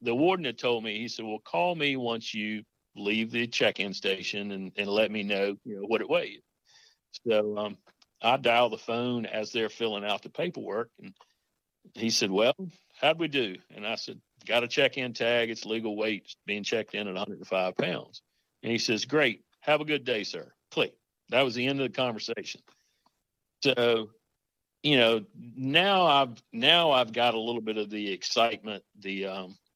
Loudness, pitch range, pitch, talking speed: -28 LUFS, 105-125 Hz, 115 Hz, 190 wpm